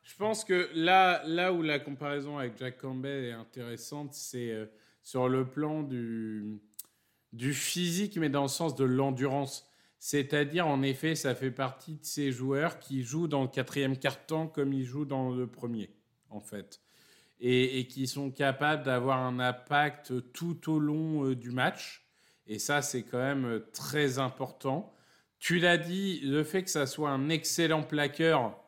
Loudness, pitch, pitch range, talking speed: -31 LUFS, 140 Hz, 125-155 Hz, 165 wpm